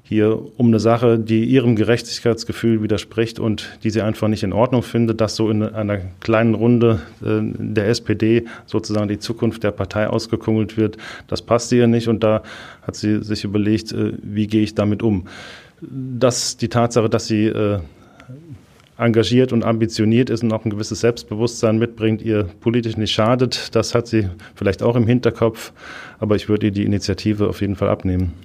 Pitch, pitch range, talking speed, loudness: 110 Hz, 105-115 Hz, 175 wpm, -19 LUFS